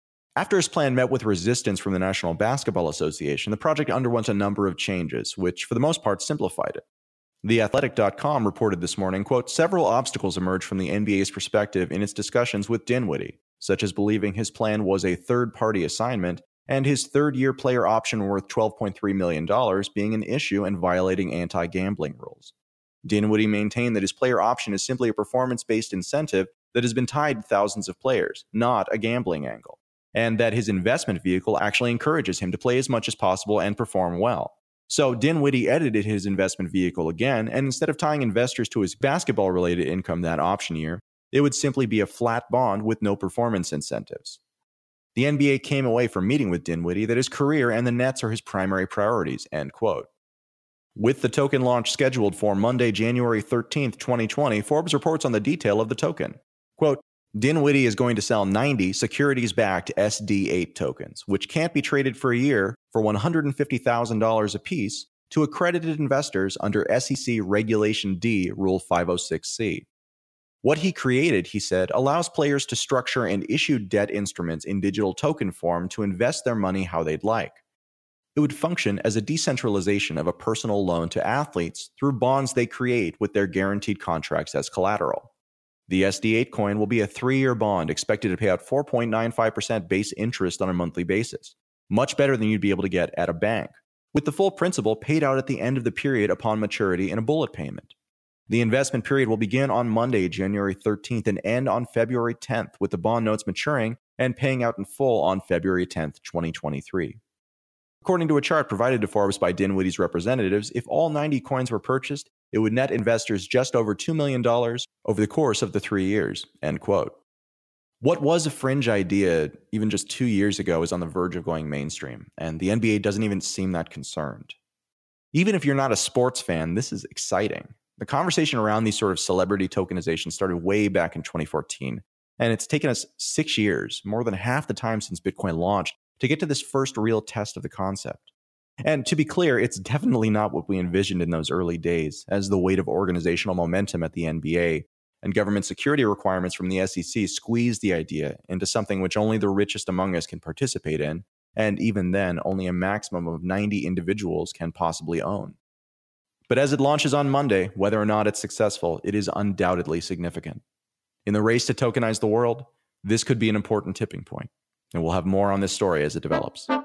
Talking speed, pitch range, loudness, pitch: 190 wpm, 95-125 Hz, -24 LUFS, 105 Hz